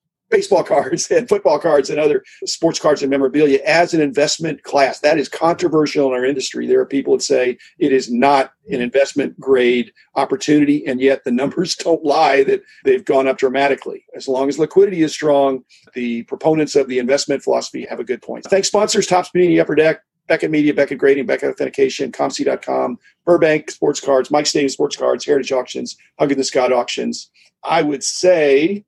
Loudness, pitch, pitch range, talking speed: -16 LUFS, 150 Hz, 135-180 Hz, 185 wpm